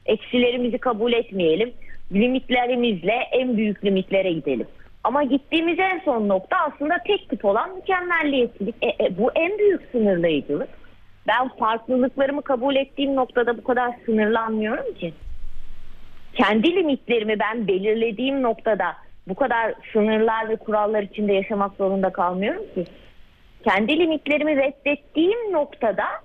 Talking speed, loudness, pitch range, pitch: 120 wpm, -22 LUFS, 205-280 Hz, 235 Hz